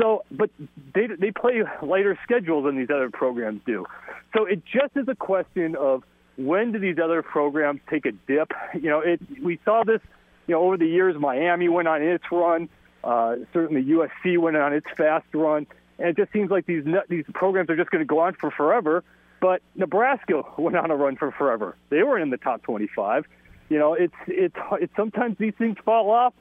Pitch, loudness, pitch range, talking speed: 175 Hz, -23 LUFS, 155-205 Hz, 210 wpm